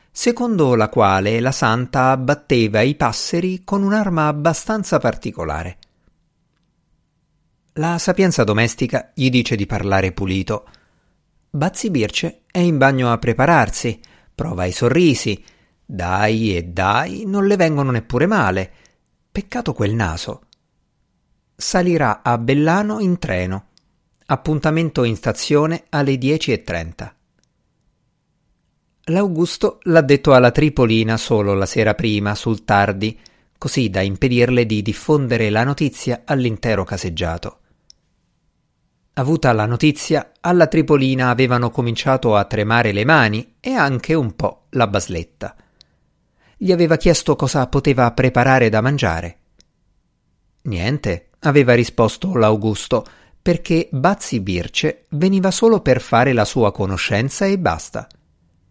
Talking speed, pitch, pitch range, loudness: 115 wpm, 125 Hz, 105-155 Hz, -17 LUFS